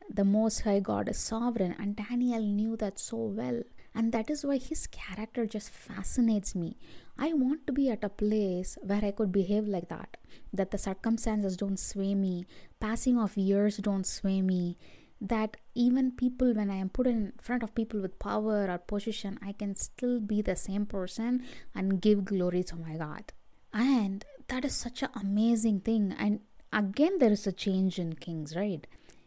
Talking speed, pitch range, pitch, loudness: 185 wpm, 195-230 Hz, 210 Hz, -31 LUFS